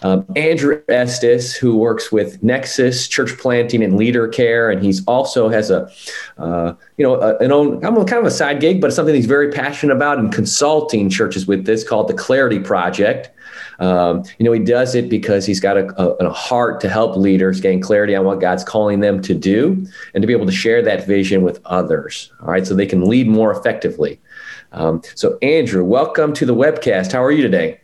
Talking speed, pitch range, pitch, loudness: 210 wpm, 95-140 Hz, 110 Hz, -15 LUFS